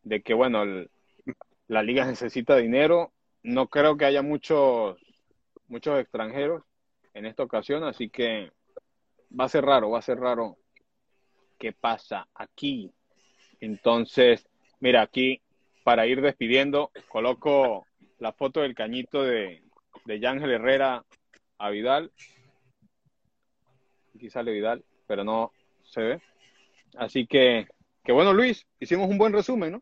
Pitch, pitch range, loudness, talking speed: 135 Hz, 125-180 Hz, -25 LUFS, 130 wpm